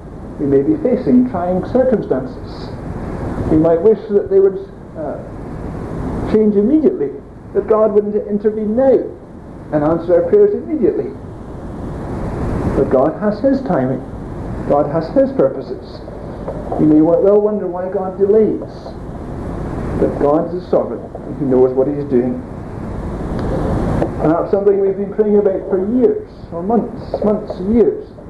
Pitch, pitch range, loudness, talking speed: 200 Hz, 160-230 Hz, -16 LUFS, 140 wpm